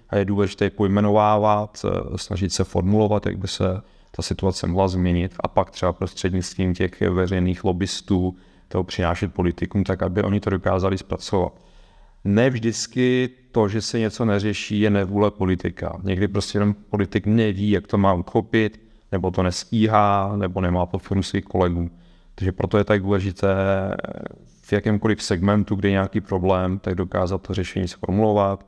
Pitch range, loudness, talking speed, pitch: 95-105 Hz, -22 LUFS, 155 wpm, 100 Hz